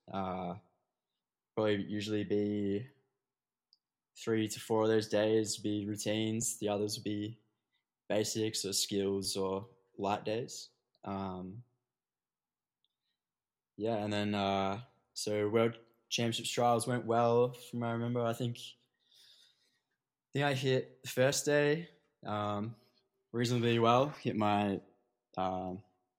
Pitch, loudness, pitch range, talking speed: 110 Hz, -34 LUFS, 100-120 Hz, 120 wpm